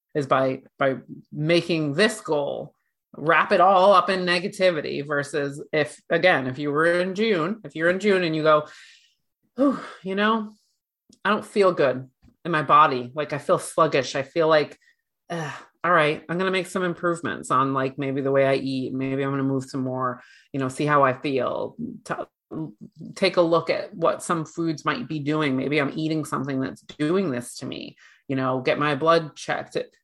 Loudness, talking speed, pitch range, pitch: -23 LUFS, 195 wpm, 135-180 Hz, 155 Hz